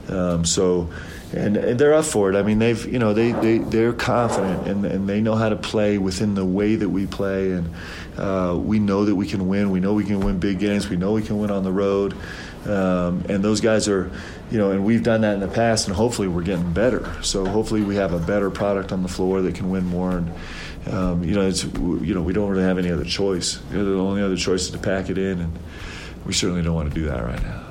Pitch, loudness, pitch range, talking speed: 95 Hz, -21 LUFS, 90-105 Hz, 260 wpm